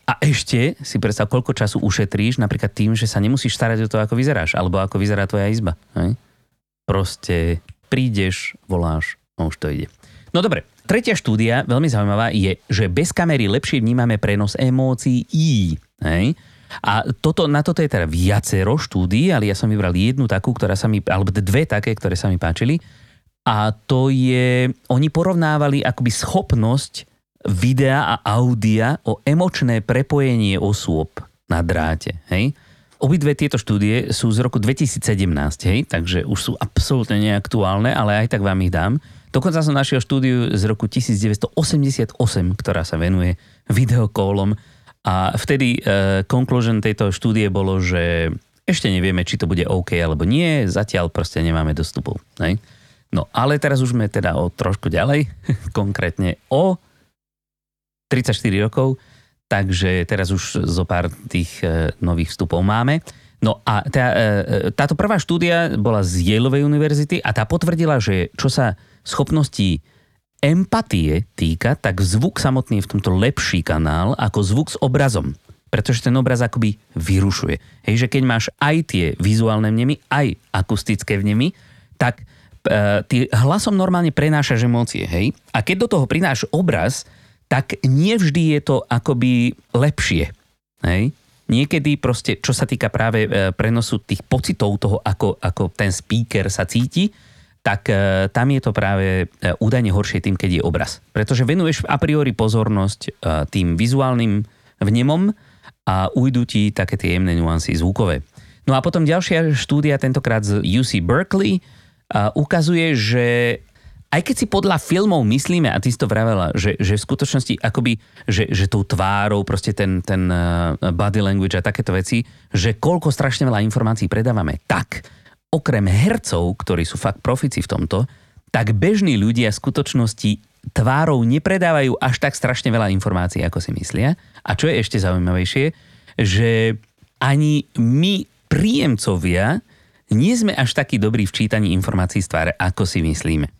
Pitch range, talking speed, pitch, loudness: 100-135 Hz, 150 wpm, 115 Hz, -18 LUFS